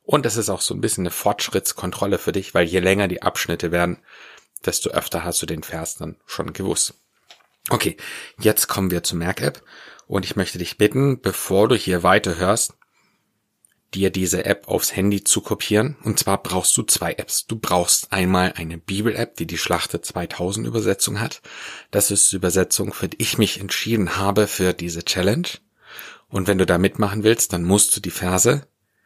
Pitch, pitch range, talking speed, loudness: 95 Hz, 90-105 Hz, 185 wpm, -20 LUFS